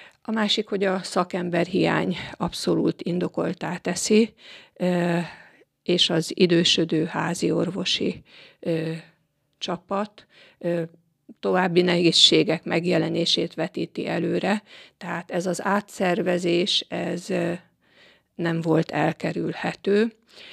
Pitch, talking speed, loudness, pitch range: 175 Hz, 80 wpm, -23 LUFS, 165-185 Hz